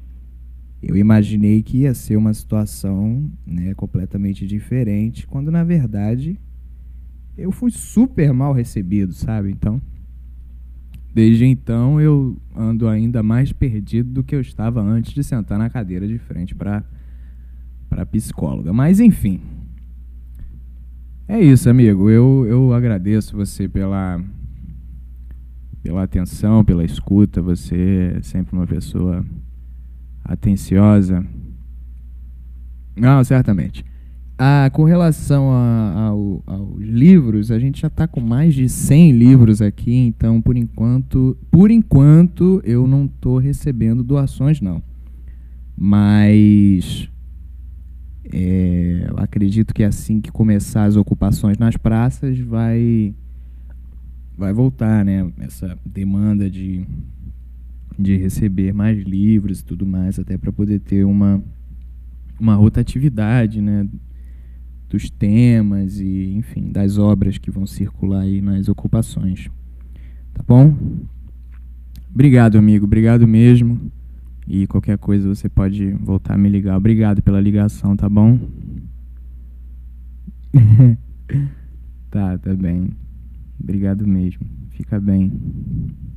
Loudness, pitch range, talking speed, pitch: -16 LUFS, 70-115 Hz, 115 wpm, 100 Hz